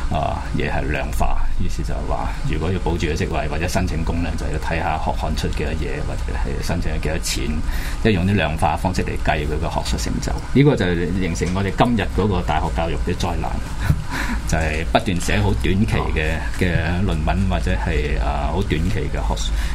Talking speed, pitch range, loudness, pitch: 305 characters per minute, 75-95 Hz, -22 LUFS, 85 Hz